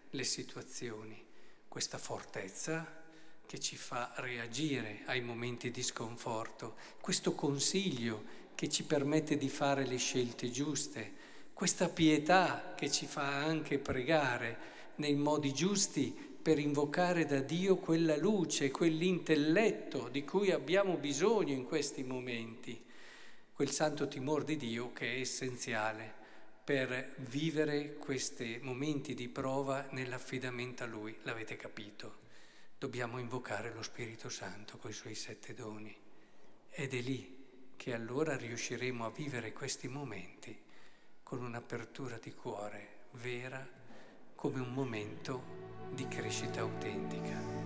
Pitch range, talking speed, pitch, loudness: 120-150 Hz, 120 wpm, 135 Hz, -37 LUFS